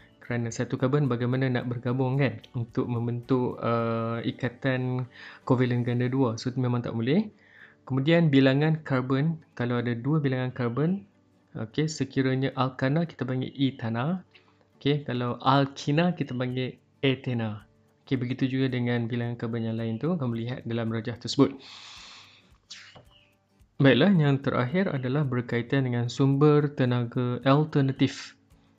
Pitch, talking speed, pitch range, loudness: 125 Hz, 130 wpm, 120-135 Hz, -27 LUFS